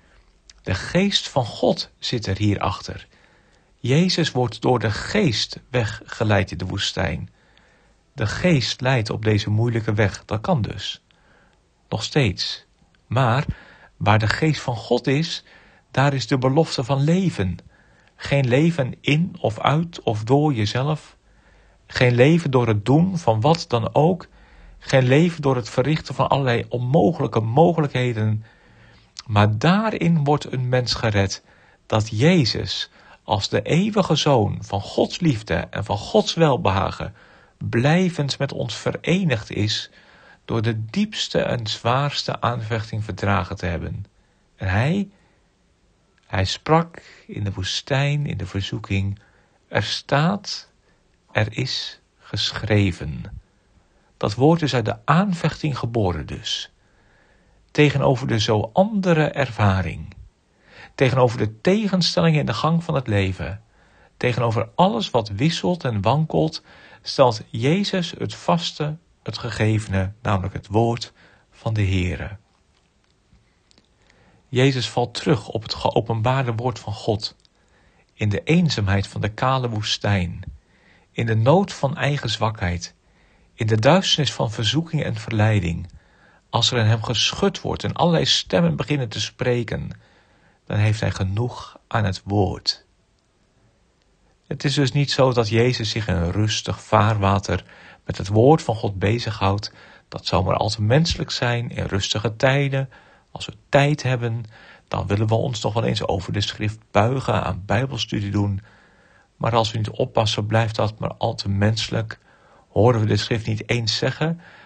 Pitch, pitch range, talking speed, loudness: 115 Hz, 105-140 Hz, 140 wpm, -21 LUFS